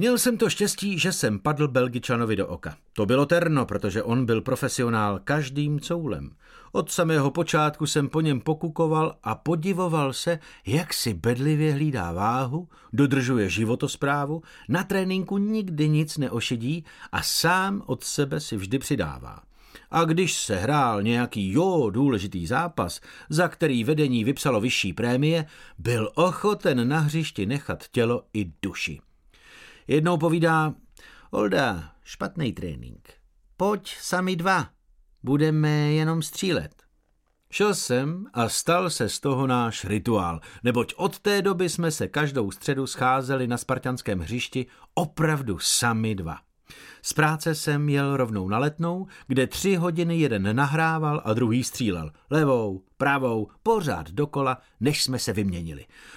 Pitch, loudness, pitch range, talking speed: 140 Hz, -25 LUFS, 120-165 Hz, 135 wpm